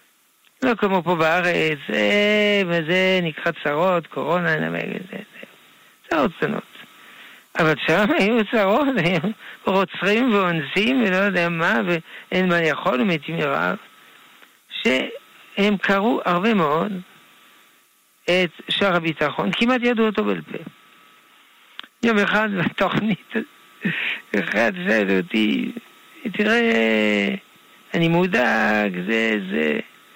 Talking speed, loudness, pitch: 95 wpm, -20 LUFS, 180 Hz